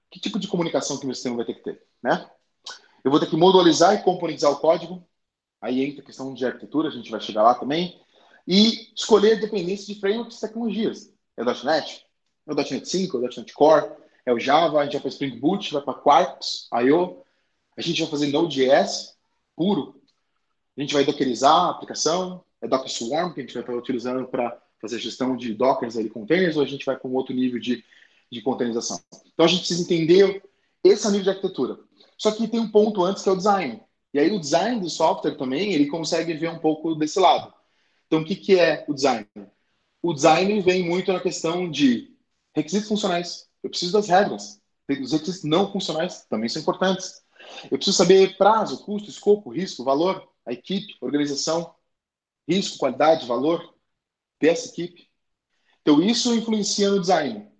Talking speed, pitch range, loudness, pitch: 195 wpm, 135-195 Hz, -22 LUFS, 165 Hz